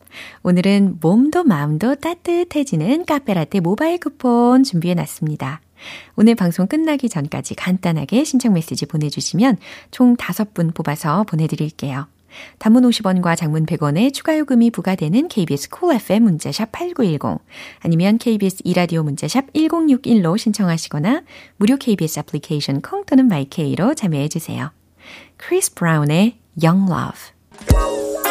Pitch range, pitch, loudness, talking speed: 160-255 Hz, 195 Hz, -17 LUFS, 330 characters per minute